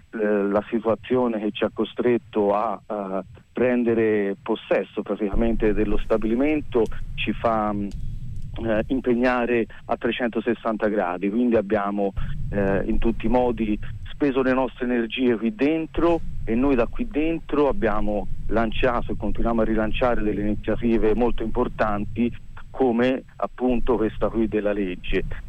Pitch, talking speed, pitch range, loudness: 115 Hz, 120 wpm, 105-120 Hz, -24 LUFS